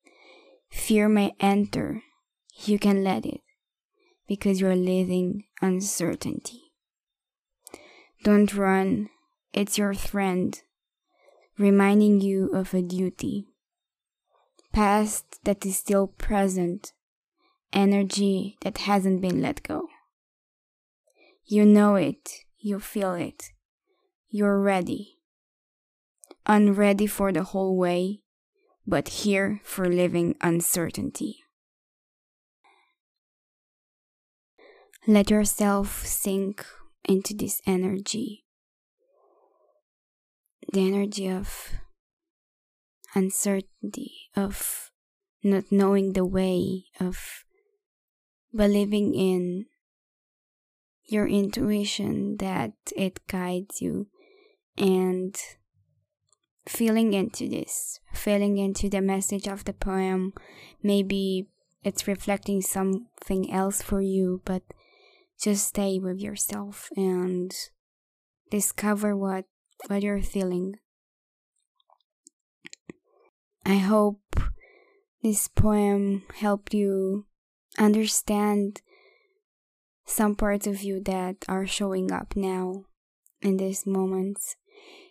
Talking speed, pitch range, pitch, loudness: 85 wpm, 190-215 Hz, 200 Hz, -26 LUFS